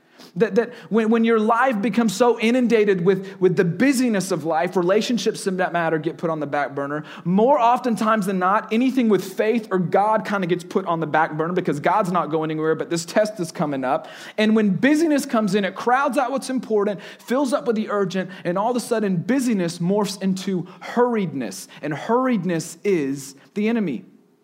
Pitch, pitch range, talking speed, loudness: 200 Hz, 175-230 Hz, 200 wpm, -21 LUFS